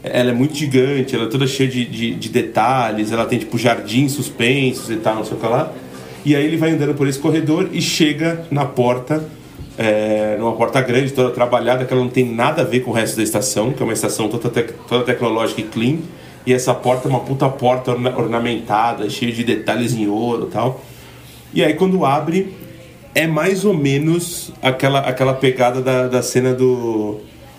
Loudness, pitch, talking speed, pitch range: -17 LUFS, 125 Hz, 205 wpm, 120-140 Hz